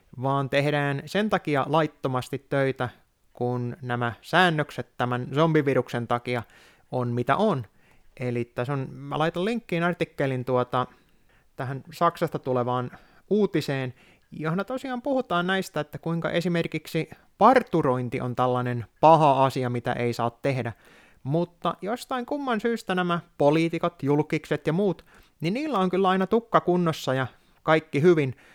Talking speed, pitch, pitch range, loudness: 130 wpm, 150 Hz, 125-175 Hz, -25 LUFS